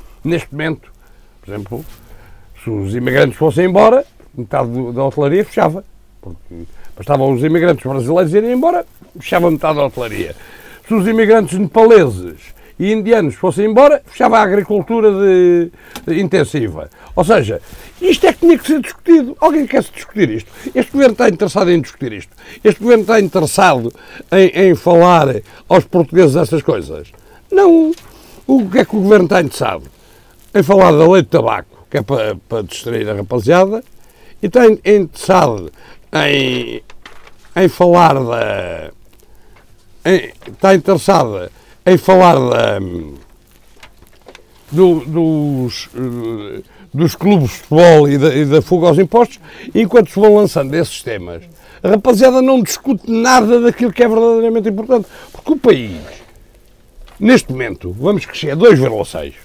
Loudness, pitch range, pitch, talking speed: -12 LUFS, 135-225 Hz, 180 Hz, 145 wpm